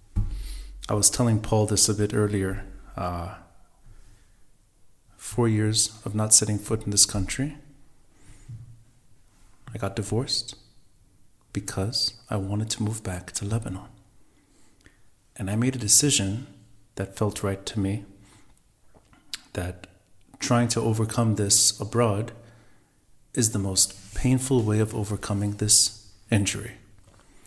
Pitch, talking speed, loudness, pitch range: 105 Hz, 120 wpm, -24 LUFS, 100-115 Hz